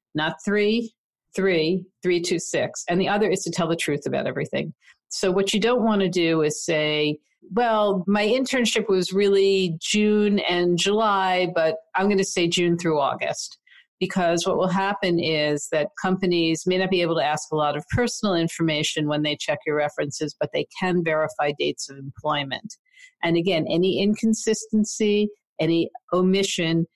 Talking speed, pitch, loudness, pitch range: 170 wpm, 185 Hz, -23 LUFS, 160-205 Hz